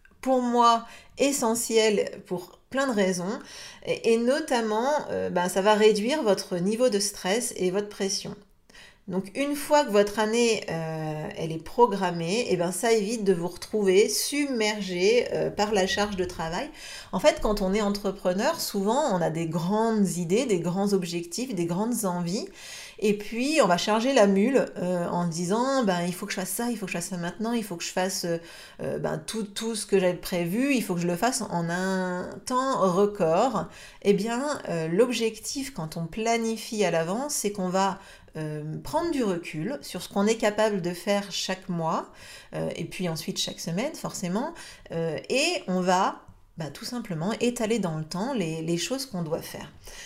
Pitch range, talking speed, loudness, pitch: 180-230 Hz, 190 wpm, -26 LUFS, 200 Hz